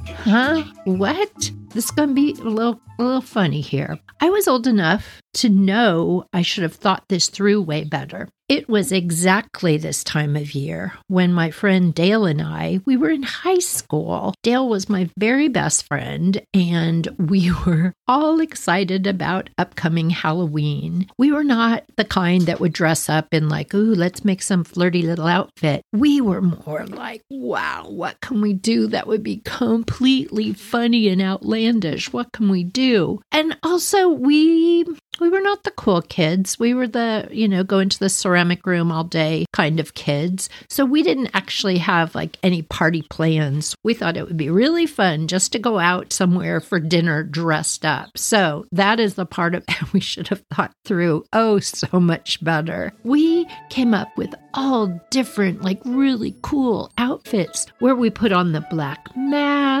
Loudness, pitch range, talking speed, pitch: -19 LUFS, 170-235 Hz, 180 wpm, 195 Hz